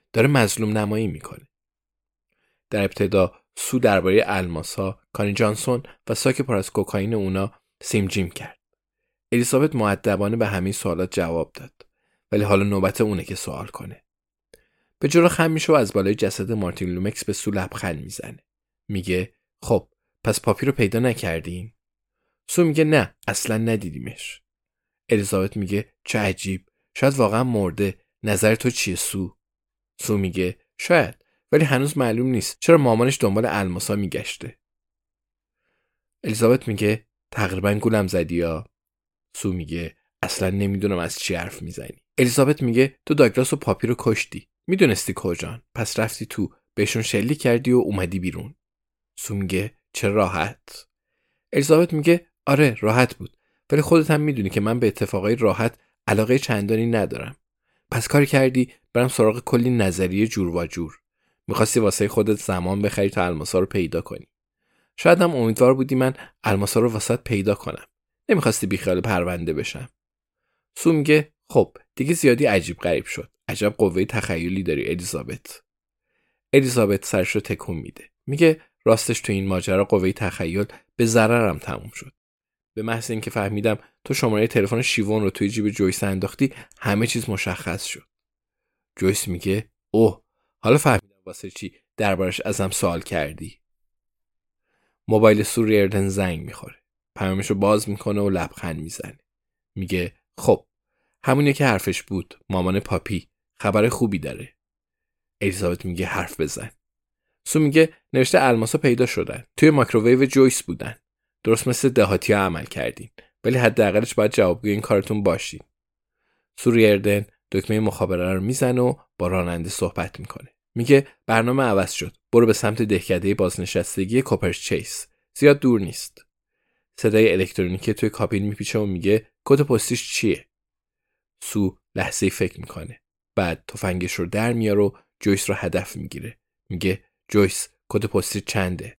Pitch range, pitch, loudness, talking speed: 95-120 Hz, 105 Hz, -21 LUFS, 145 wpm